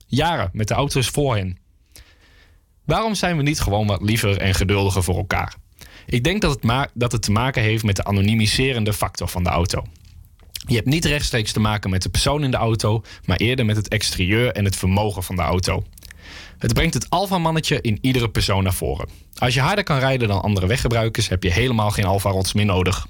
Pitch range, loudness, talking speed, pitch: 95-125 Hz, -20 LUFS, 210 wpm, 105 Hz